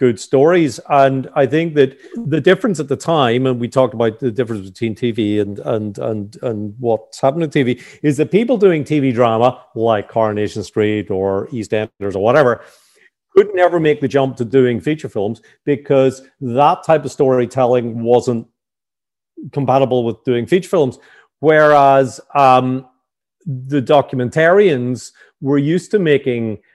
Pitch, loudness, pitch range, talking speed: 130 Hz, -15 LUFS, 115-145 Hz, 155 wpm